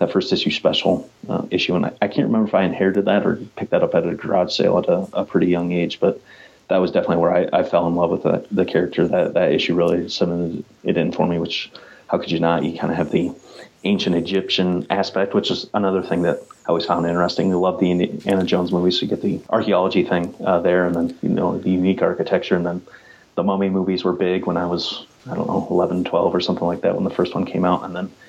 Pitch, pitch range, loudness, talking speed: 90 Hz, 85-95 Hz, -20 LUFS, 260 wpm